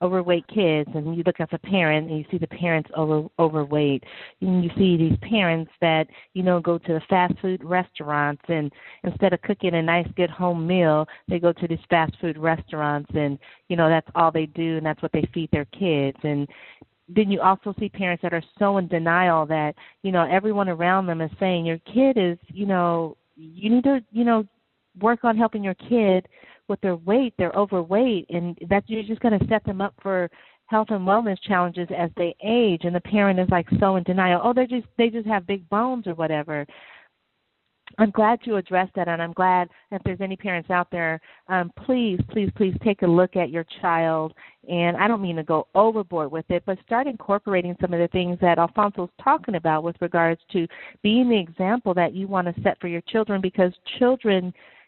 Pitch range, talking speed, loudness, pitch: 165-200 Hz, 210 wpm, -23 LUFS, 180 Hz